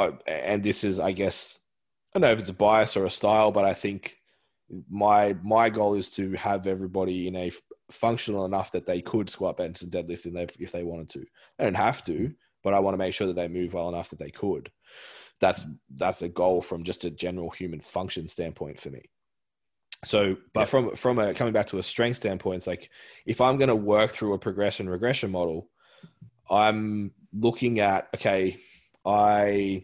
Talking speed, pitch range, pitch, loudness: 205 wpm, 90-105 Hz, 100 Hz, -26 LUFS